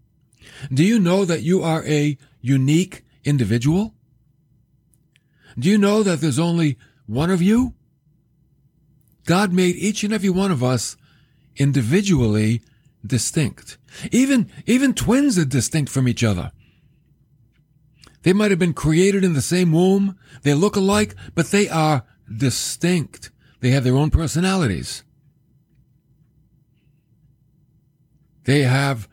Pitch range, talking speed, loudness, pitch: 135-175 Hz, 120 wpm, -19 LUFS, 145 Hz